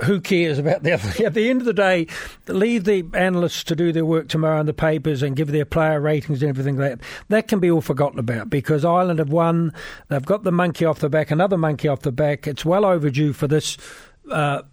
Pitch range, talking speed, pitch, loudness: 150-180 Hz, 240 wpm, 160 Hz, -20 LUFS